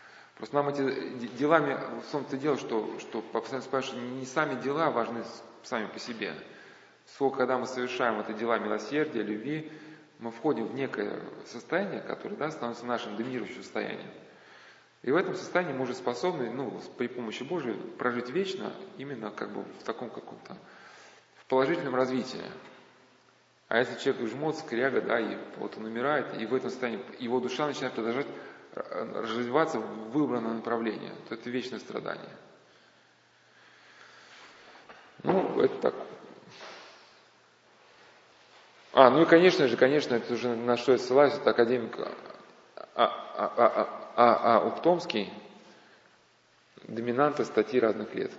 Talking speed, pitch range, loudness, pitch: 140 wpm, 120-150 Hz, -29 LUFS, 130 Hz